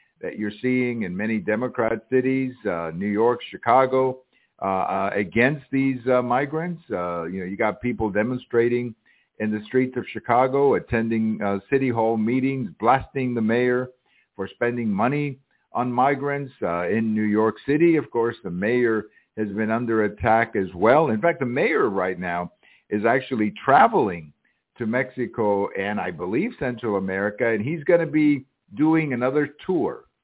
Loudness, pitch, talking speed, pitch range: -23 LUFS, 120 Hz, 160 wpm, 110-130 Hz